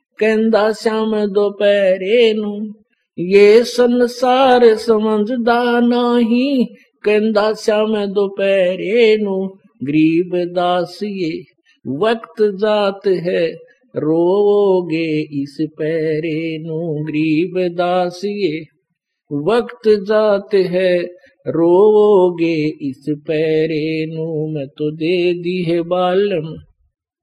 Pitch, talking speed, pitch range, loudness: 190 Hz, 75 wpm, 165-215 Hz, -16 LUFS